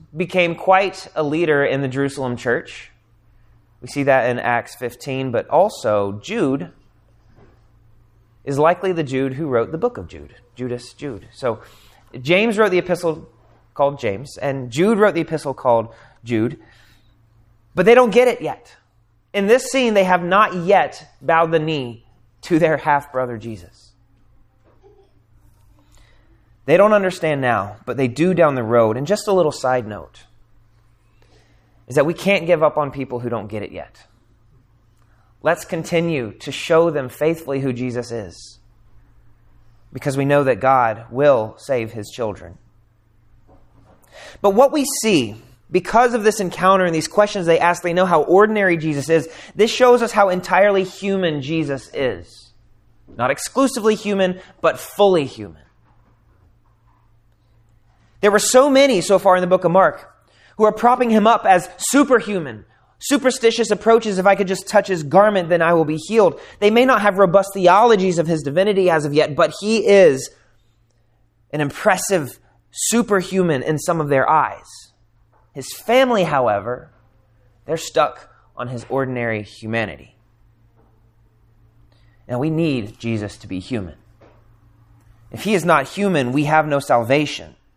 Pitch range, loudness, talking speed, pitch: 115-180 Hz, -17 LUFS, 155 wpm, 135 Hz